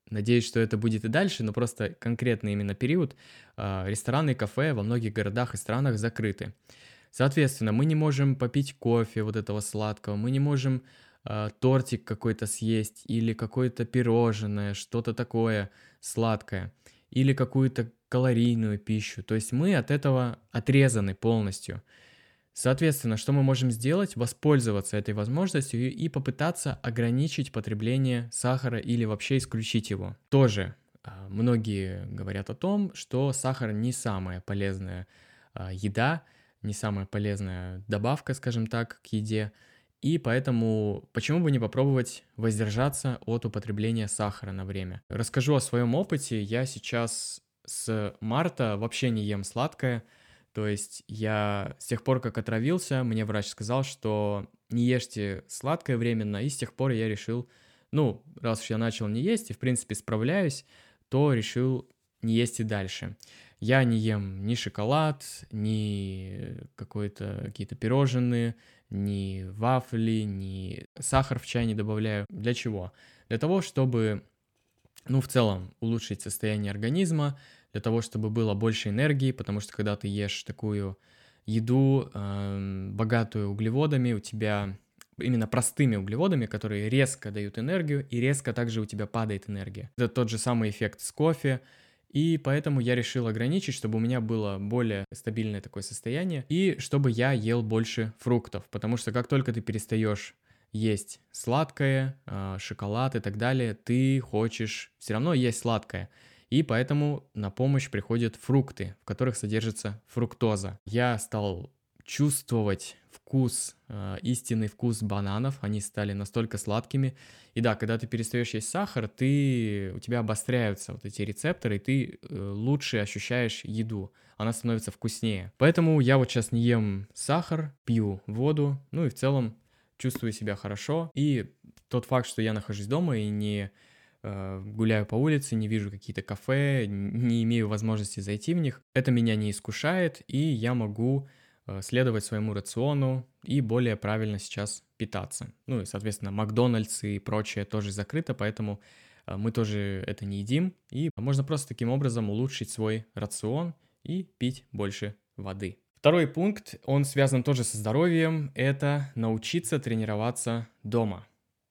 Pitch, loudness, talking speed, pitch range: 115 Hz, -29 LUFS, 145 wpm, 105-130 Hz